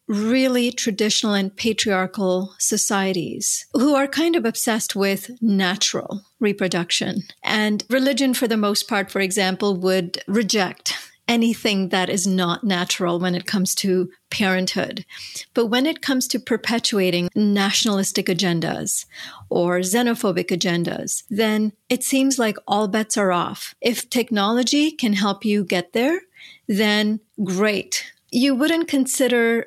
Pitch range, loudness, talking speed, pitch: 190-240 Hz, -20 LUFS, 130 wpm, 210 Hz